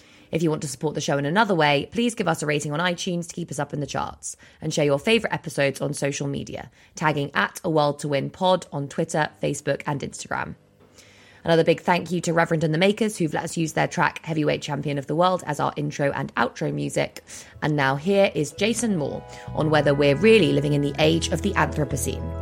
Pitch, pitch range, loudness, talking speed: 155 Hz, 140-175 Hz, -23 LUFS, 235 wpm